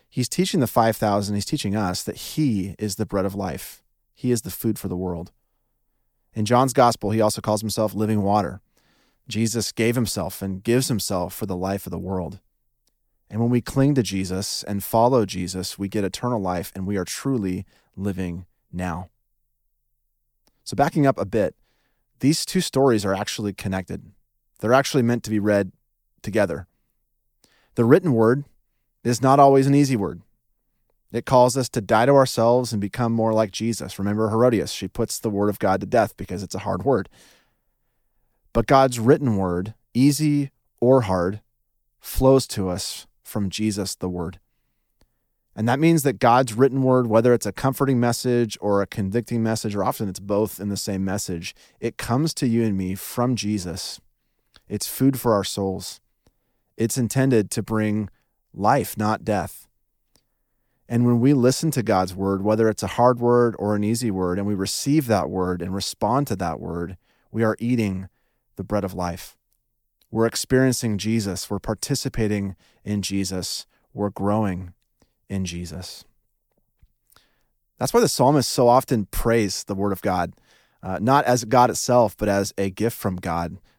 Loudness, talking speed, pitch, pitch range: -22 LUFS, 170 wpm, 110 Hz, 95-120 Hz